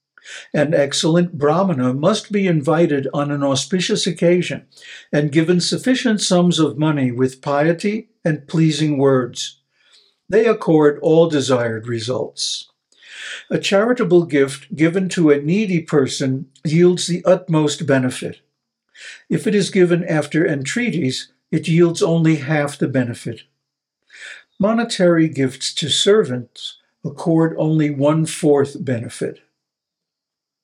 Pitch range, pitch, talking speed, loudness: 140-180 Hz, 160 Hz, 115 wpm, -17 LUFS